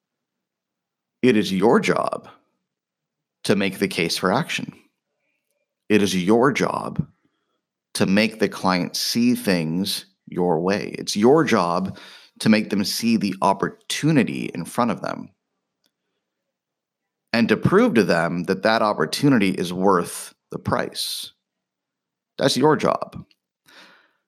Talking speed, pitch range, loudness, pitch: 125 wpm, 90-105 Hz, -21 LUFS, 100 Hz